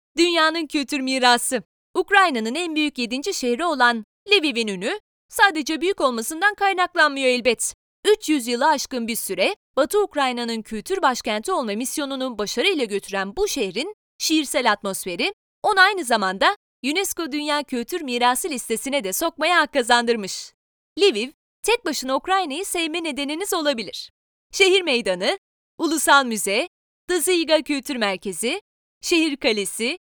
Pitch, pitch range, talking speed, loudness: 290 Hz, 240-350 Hz, 120 wpm, -21 LUFS